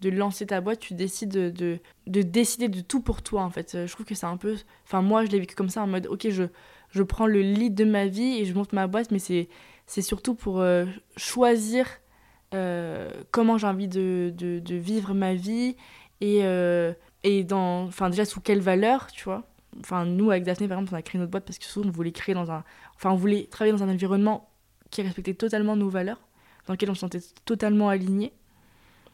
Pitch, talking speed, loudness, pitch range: 195 Hz, 230 wpm, -26 LUFS, 185-215 Hz